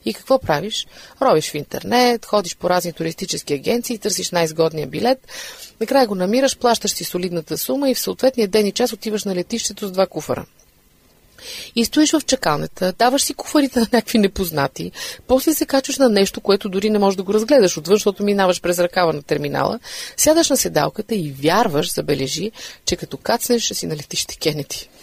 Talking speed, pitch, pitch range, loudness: 180 wpm, 210 Hz, 175-245 Hz, -19 LUFS